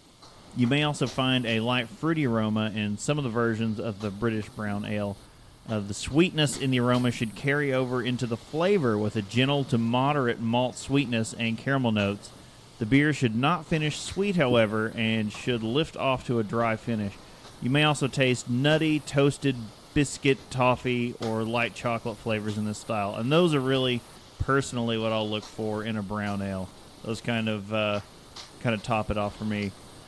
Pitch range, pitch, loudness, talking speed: 110-135 Hz, 120 Hz, -27 LUFS, 190 wpm